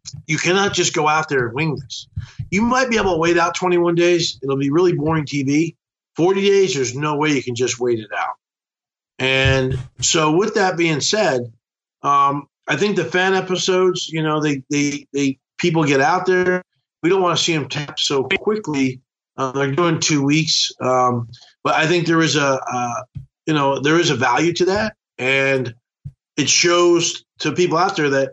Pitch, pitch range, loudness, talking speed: 150 Hz, 135-175 Hz, -18 LUFS, 190 wpm